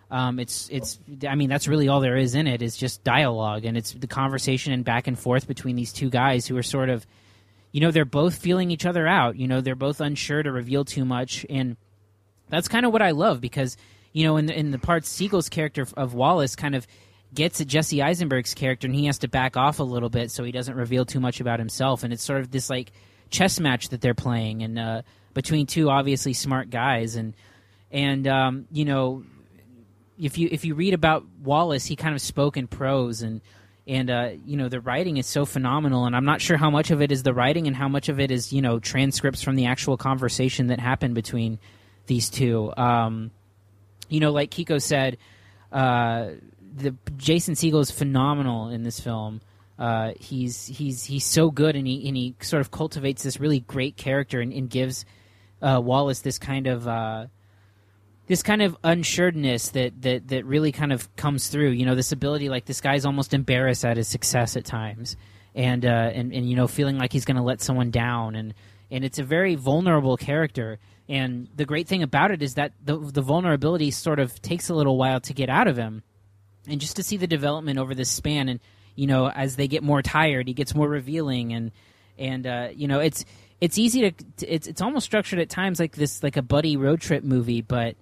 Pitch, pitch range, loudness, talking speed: 130 Hz, 120-145 Hz, -24 LUFS, 220 wpm